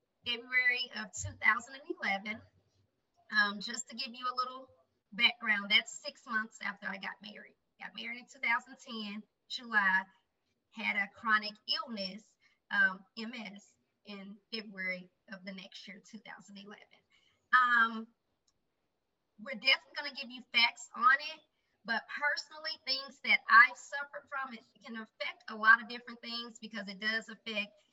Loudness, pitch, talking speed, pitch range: -32 LUFS, 230 Hz, 140 wpm, 210-265 Hz